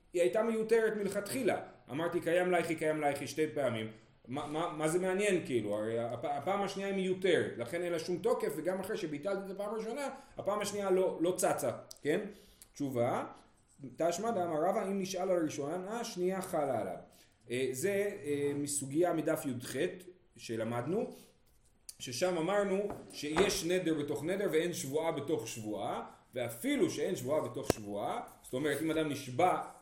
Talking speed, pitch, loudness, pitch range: 155 wpm, 170 Hz, -35 LUFS, 145-195 Hz